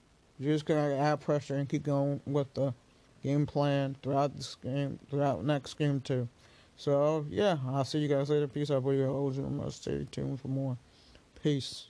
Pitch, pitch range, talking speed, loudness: 140 Hz, 135-145 Hz, 190 wpm, -32 LUFS